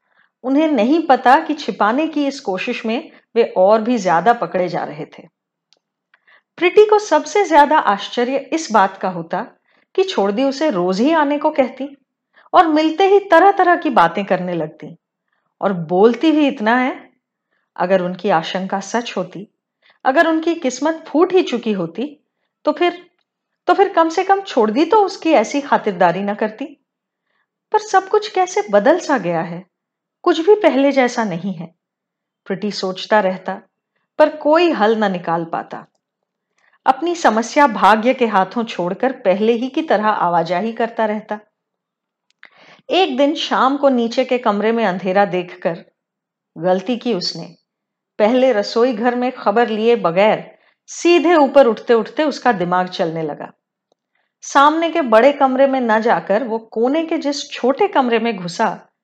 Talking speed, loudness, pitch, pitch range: 155 wpm, -16 LUFS, 240 Hz, 200-300 Hz